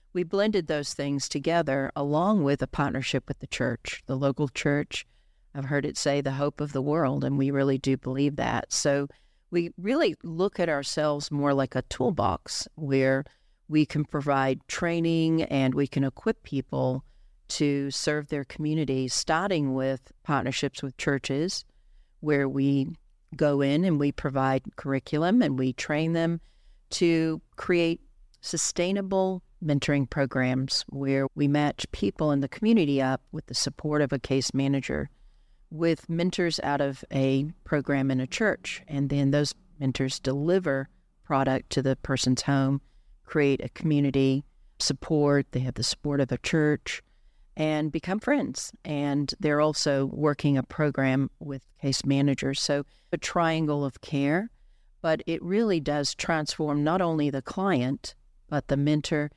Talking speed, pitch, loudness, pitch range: 150 wpm, 145 Hz, -27 LUFS, 135-160 Hz